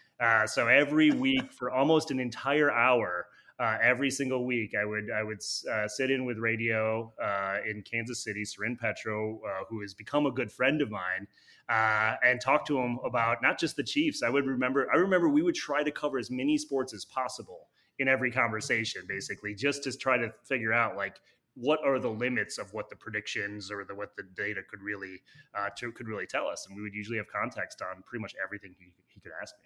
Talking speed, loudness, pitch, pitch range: 220 wpm, -30 LUFS, 120 Hz, 105-135 Hz